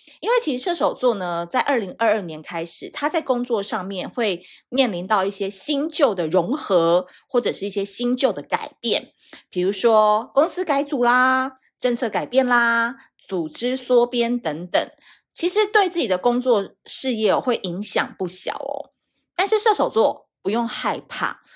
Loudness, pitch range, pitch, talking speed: -21 LUFS, 200-275 Hz, 245 Hz, 240 characters per minute